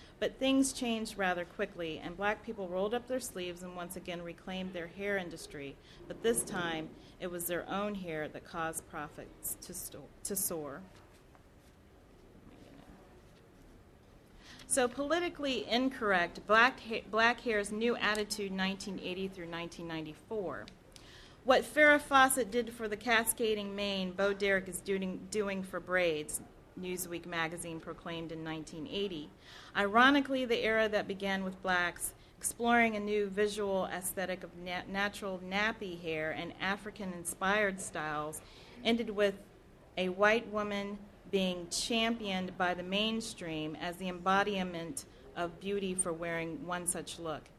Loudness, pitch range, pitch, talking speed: -34 LUFS, 175-215 Hz, 190 Hz, 135 wpm